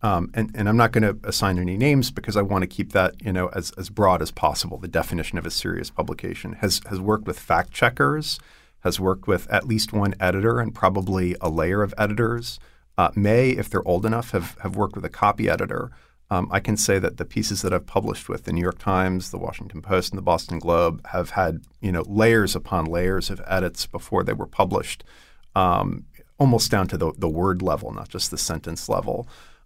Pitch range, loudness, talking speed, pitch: 90-110 Hz, -23 LUFS, 220 wpm, 95 Hz